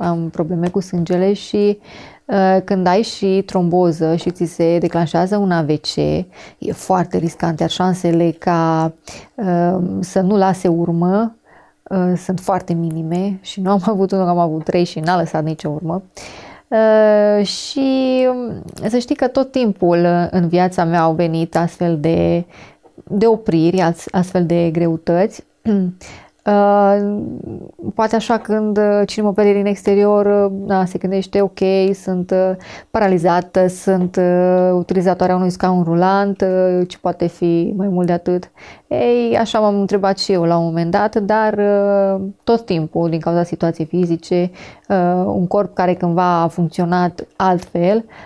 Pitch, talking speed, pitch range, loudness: 185 Hz, 140 wpm, 175-200 Hz, -16 LUFS